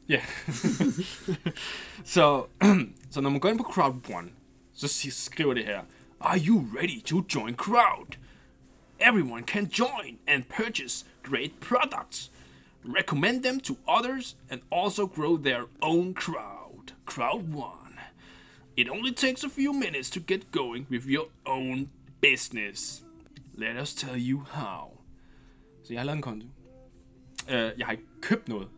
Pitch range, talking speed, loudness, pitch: 130-205 Hz, 135 wpm, -28 LUFS, 150 Hz